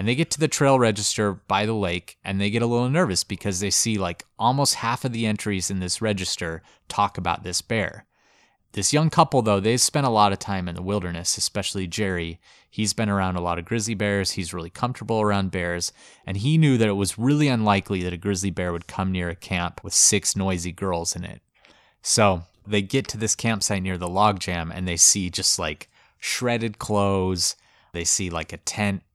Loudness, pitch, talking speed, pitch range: -23 LUFS, 100 Hz, 215 wpm, 90-110 Hz